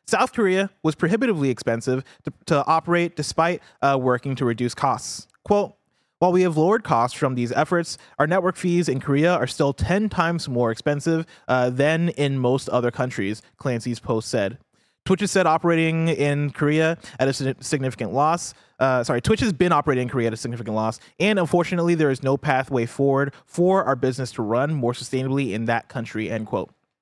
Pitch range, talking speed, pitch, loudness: 125-170 Hz, 185 wpm, 140 Hz, -22 LUFS